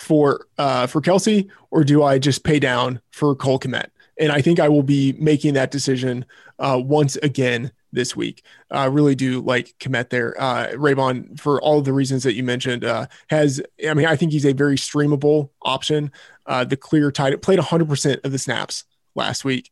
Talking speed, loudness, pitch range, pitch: 200 wpm, -19 LUFS, 130-150 Hz, 140 Hz